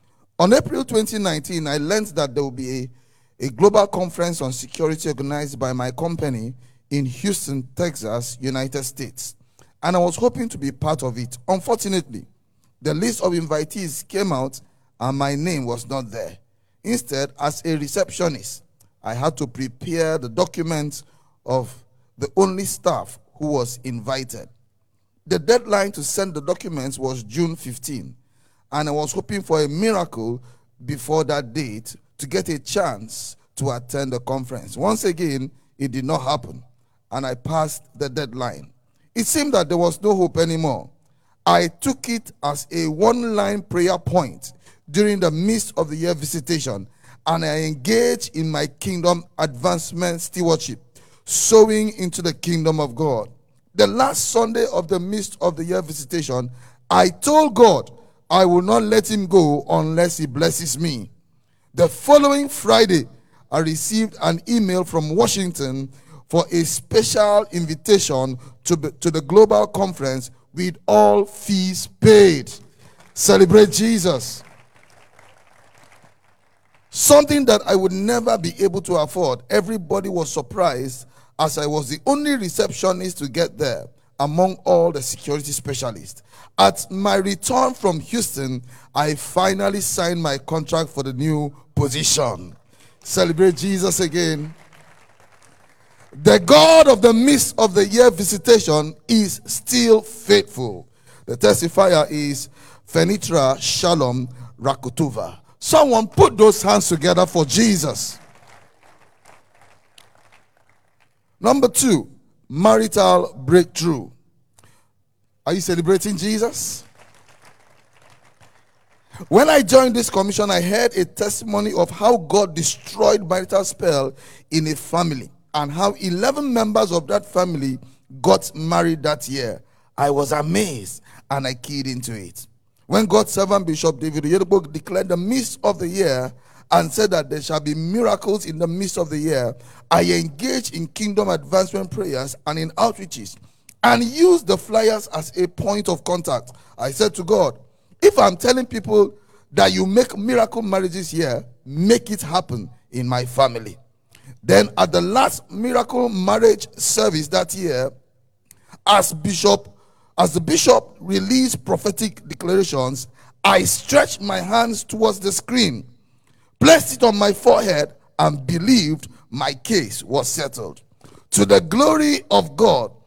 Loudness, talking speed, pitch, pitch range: -19 LUFS, 140 wpm, 160 Hz, 130-195 Hz